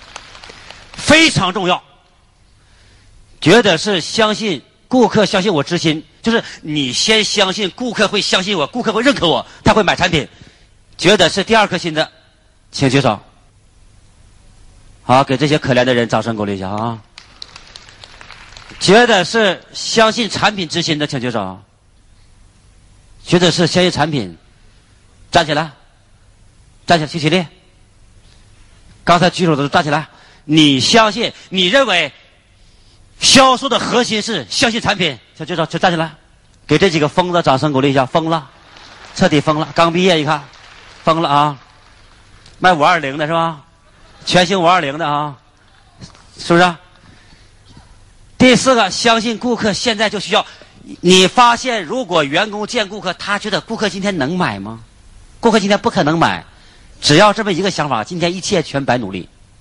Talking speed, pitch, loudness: 225 characters per minute, 150 Hz, -14 LUFS